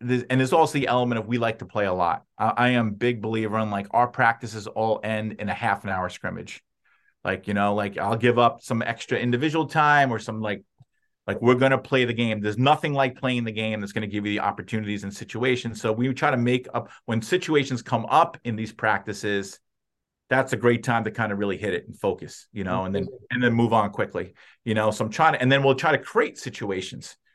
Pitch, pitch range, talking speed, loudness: 115 Hz, 105-125 Hz, 240 wpm, -24 LUFS